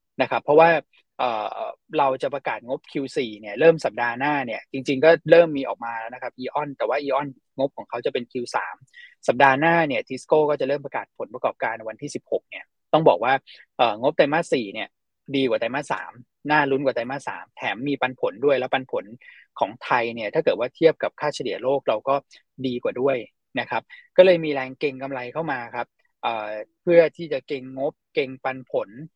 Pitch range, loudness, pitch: 130-165 Hz, -23 LUFS, 140 Hz